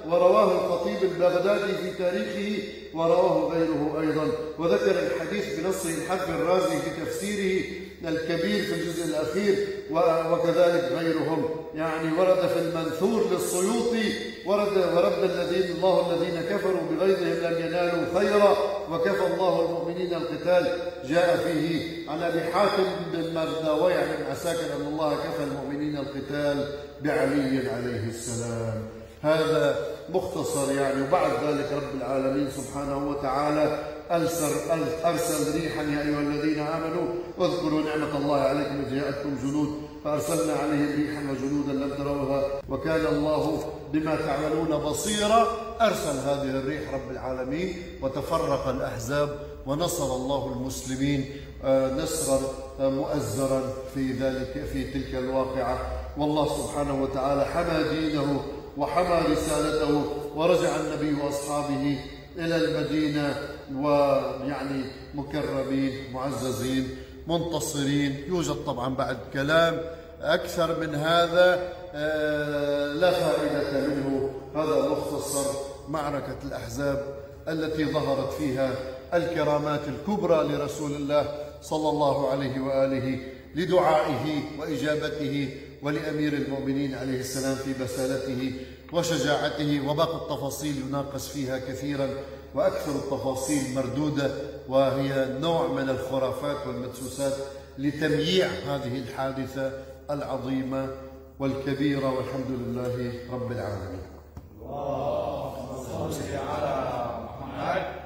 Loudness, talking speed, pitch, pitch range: -27 LUFS, 100 wpm, 145 Hz, 135-165 Hz